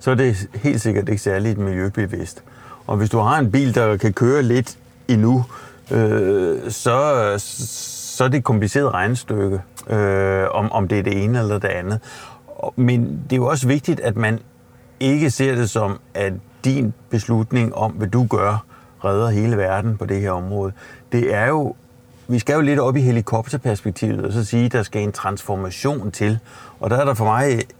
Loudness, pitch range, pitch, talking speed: -20 LUFS, 105-125 Hz, 115 Hz, 190 wpm